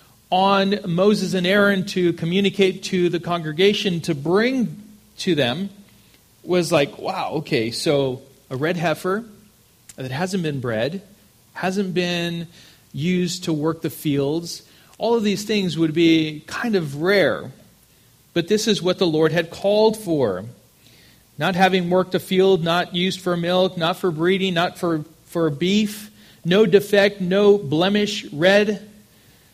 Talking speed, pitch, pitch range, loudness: 145 wpm, 180 Hz, 165-200 Hz, -20 LUFS